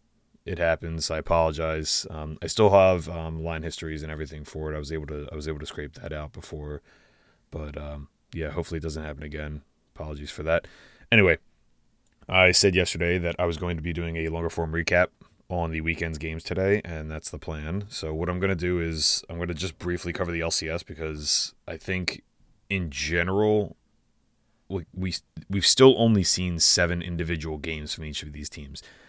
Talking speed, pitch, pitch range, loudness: 195 wpm, 85 Hz, 80-90 Hz, -25 LUFS